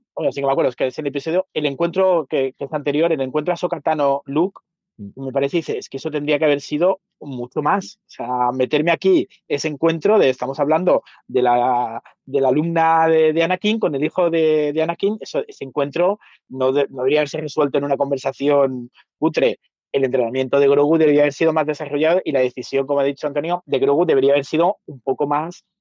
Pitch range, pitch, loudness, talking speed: 140-165 Hz, 150 Hz, -19 LUFS, 220 wpm